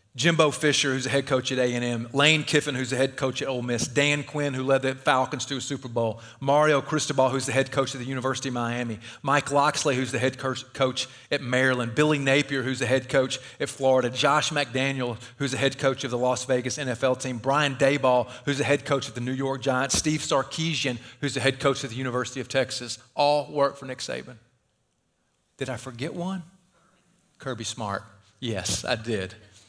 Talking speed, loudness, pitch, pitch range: 205 wpm, -25 LUFS, 135 Hz, 125-145 Hz